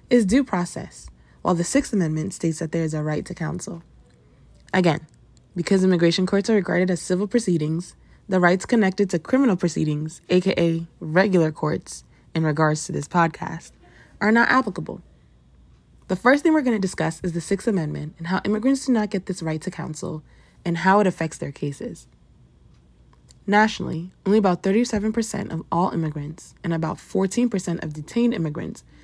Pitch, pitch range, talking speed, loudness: 175 Hz, 160-200 Hz, 165 wpm, -22 LUFS